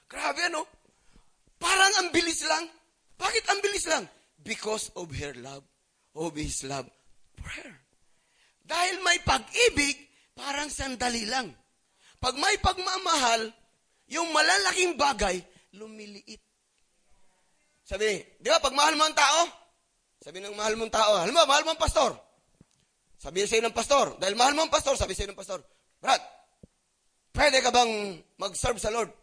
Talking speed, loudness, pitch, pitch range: 145 wpm, -26 LUFS, 265 Hz, 210-325 Hz